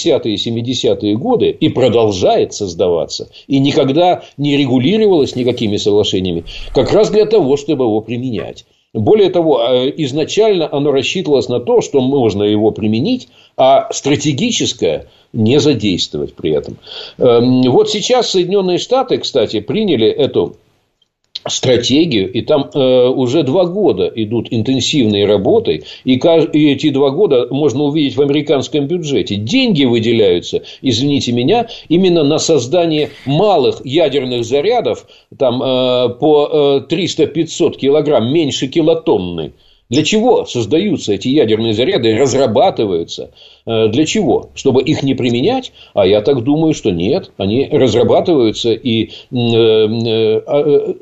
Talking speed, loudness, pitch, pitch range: 125 wpm, -13 LUFS, 140 Hz, 120-170 Hz